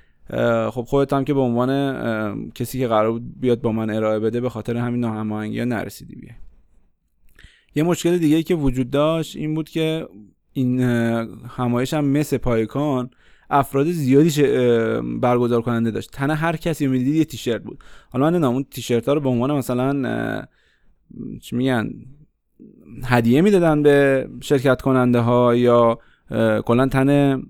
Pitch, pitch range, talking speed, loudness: 125 Hz, 115-140 Hz, 145 wpm, -20 LUFS